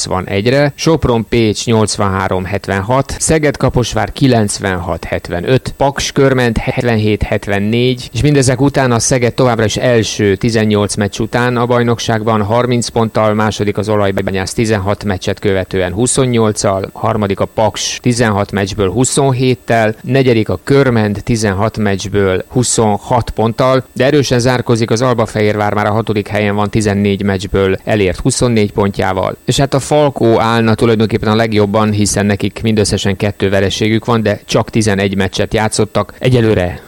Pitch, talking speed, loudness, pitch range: 110 Hz, 130 wpm, -13 LUFS, 100-125 Hz